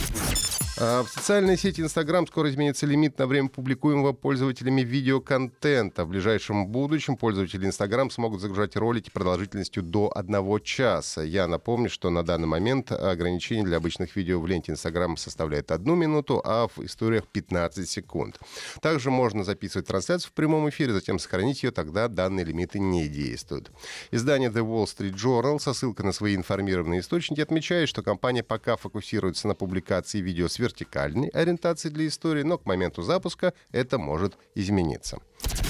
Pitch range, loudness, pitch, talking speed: 95-140 Hz, -26 LUFS, 110 Hz, 155 wpm